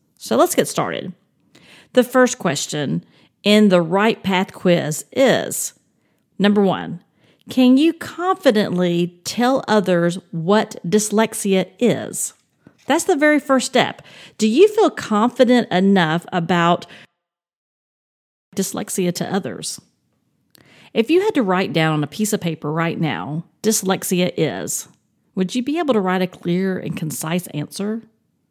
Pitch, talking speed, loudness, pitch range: 195 Hz, 135 wpm, -18 LUFS, 175-240 Hz